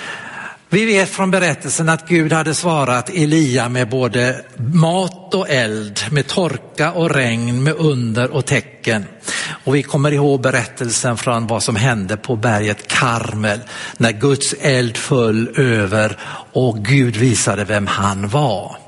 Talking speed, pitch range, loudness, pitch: 145 wpm, 115-155 Hz, -16 LUFS, 130 Hz